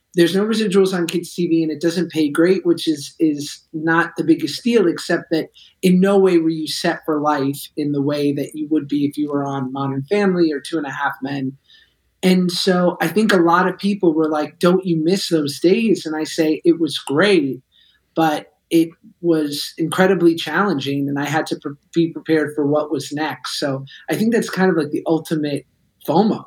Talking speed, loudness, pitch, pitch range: 215 wpm, -18 LUFS, 160 Hz, 150-180 Hz